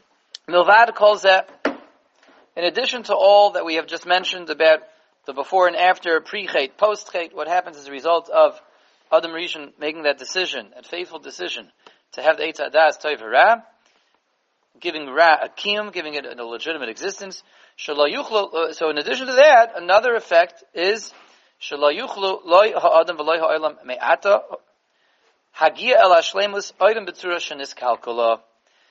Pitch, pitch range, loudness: 170 Hz, 155-200 Hz, -19 LUFS